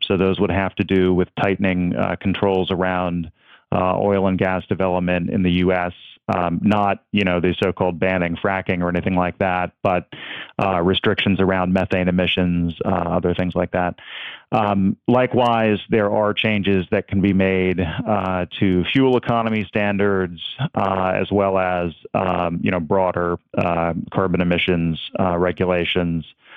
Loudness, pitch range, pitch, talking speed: -20 LUFS, 90-100 Hz, 95 Hz, 155 wpm